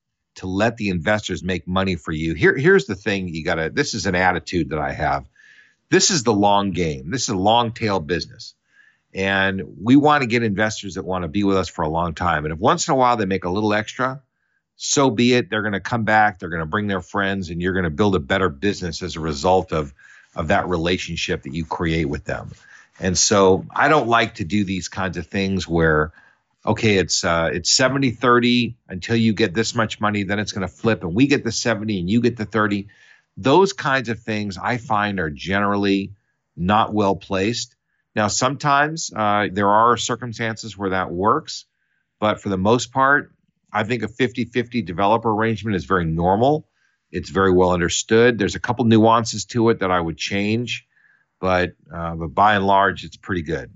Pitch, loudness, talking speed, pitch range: 100 Hz, -20 LUFS, 215 wpm, 90-115 Hz